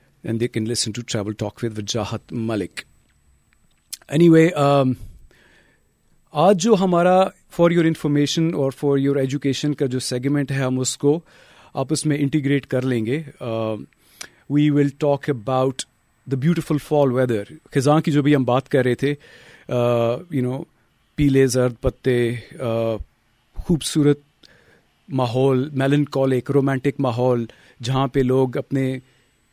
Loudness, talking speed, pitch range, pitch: -20 LUFS, 125 wpm, 125-145 Hz, 135 Hz